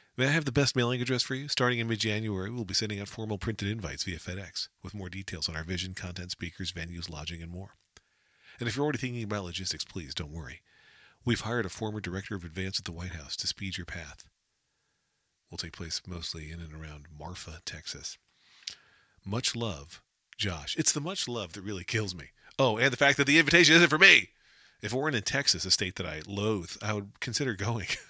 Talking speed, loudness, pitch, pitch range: 220 wpm, -29 LUFS, 100 Hz, 90-120 Hz